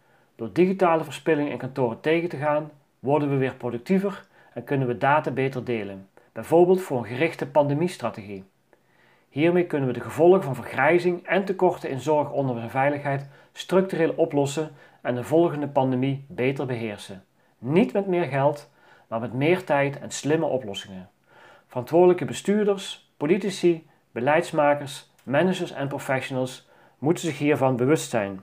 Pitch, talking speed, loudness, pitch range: 145 Hz, 145 wpm, -24 LUFS, 125-170 Hz